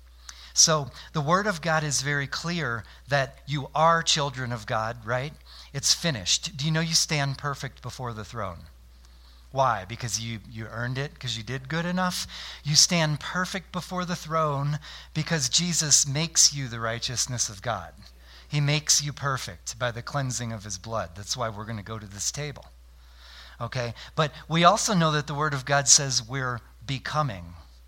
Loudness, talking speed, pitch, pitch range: -25 LUFS, 180 wpm, 135 Hz, 110-155 Hz